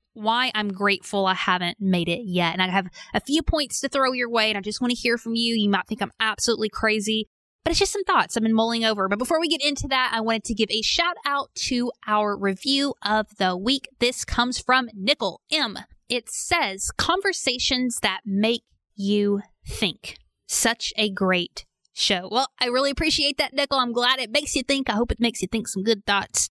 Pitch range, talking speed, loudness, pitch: 205-265 Hz, 220 wpm, -23 LUFS, 230 Hz